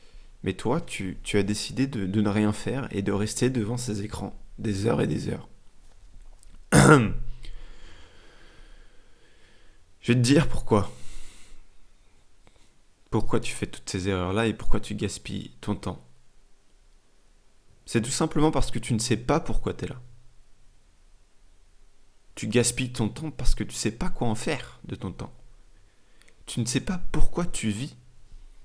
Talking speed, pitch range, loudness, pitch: 155 wpm, 100-125 Hz, -27 LUFS, 105 Hz